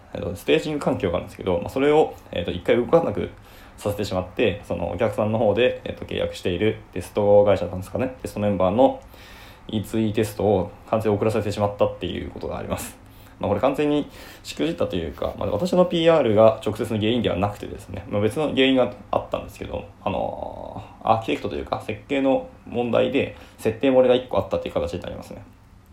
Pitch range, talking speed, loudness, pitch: 100-130 Hz, 435 characters per minute, -23 LUFS, 105 Hz